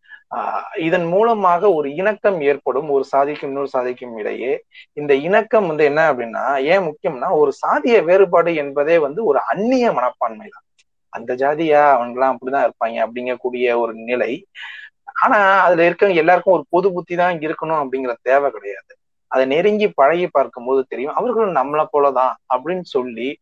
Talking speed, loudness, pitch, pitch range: 150 wpm, -17 LUFS, 150 Hz, 130-195 Hz